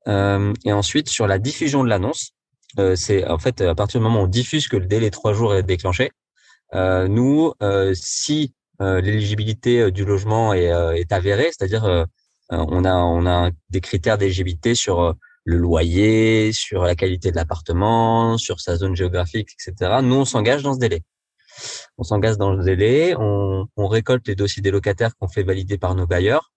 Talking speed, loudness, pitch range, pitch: 195 wpm, -19 LUFS, 90-115 Hz, 100 Hz